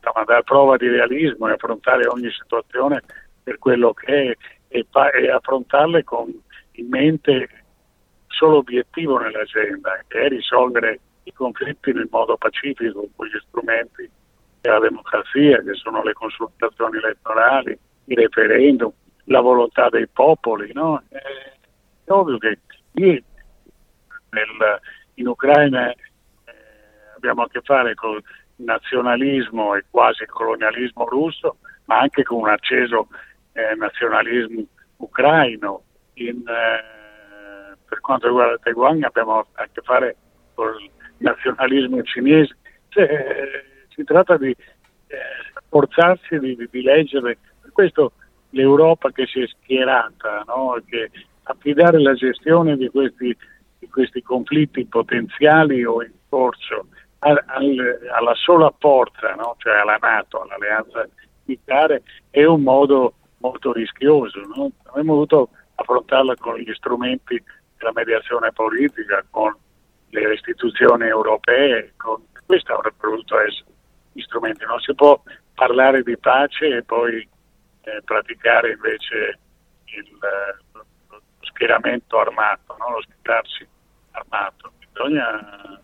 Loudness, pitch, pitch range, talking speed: -18 LUFS, 135 Hz, 120-155 Hz, 120 wpm